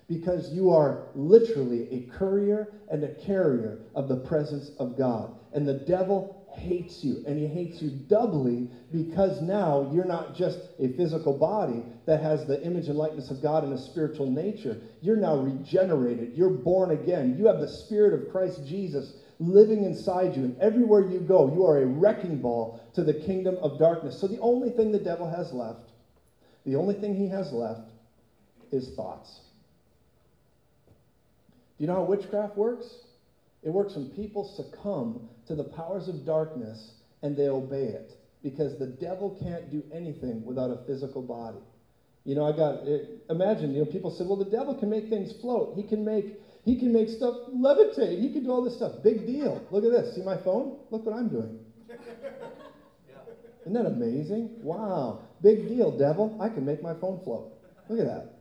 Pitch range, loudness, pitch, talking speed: 140-210 Hz, -27 LUFS, 175 Hz, 185 wpm